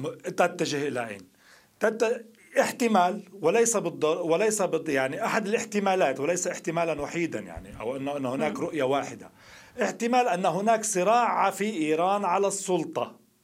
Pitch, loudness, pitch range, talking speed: 180 Hz, -26 LUFS, 160-220 Hz, 125 wpm